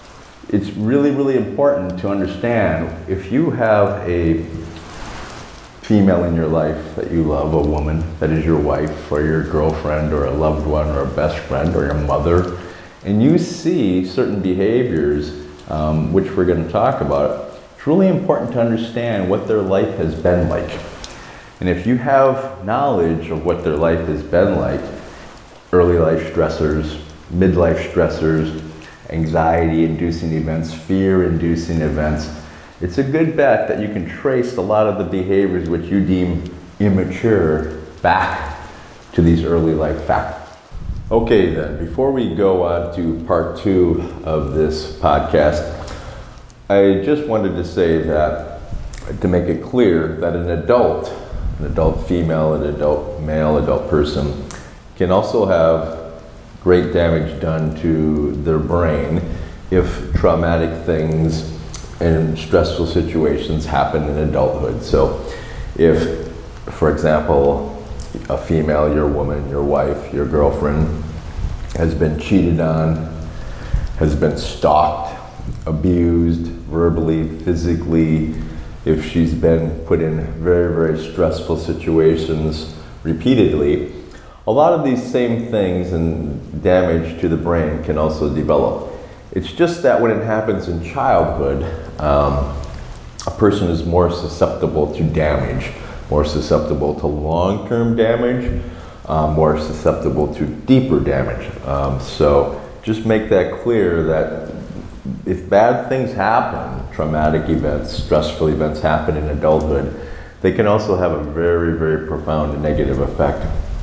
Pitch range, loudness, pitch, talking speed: 75-90 Hz, -17 LUFS, 80 Hz, 135 wpm